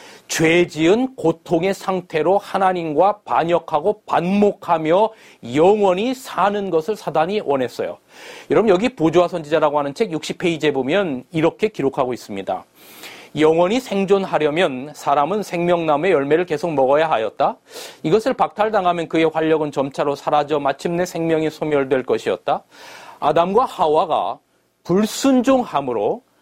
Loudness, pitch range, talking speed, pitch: -19 LUFS, 155-205 Hz, 315 characters per minute, 175 Hz